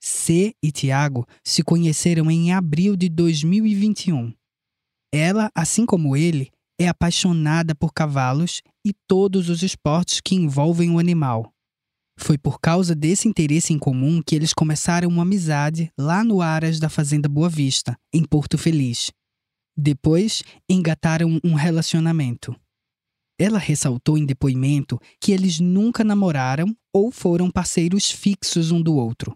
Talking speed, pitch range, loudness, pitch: 135 wpm, 145-175 Hz, -20 LUFS, 165 Hz